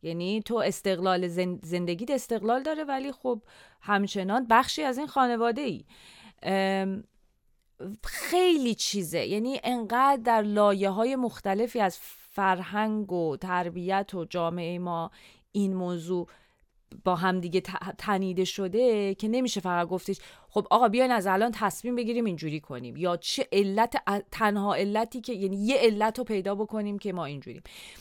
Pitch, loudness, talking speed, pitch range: 205 Hz, -28 LUFS, 145 wpm, 185-235 Hz